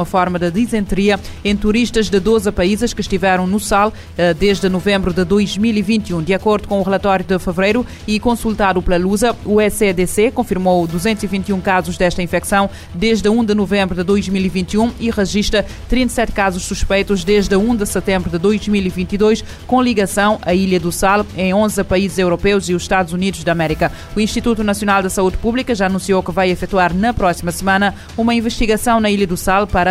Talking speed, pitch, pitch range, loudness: 180 wpm, 200 Hz, 185-215 Hz, -16 LUFS